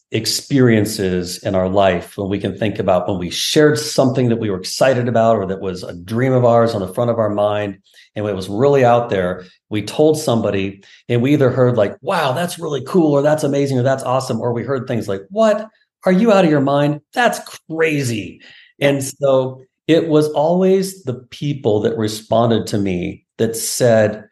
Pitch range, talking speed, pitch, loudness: 105-145 Hz, 200 wpm, 120 Hz, -17 LUFS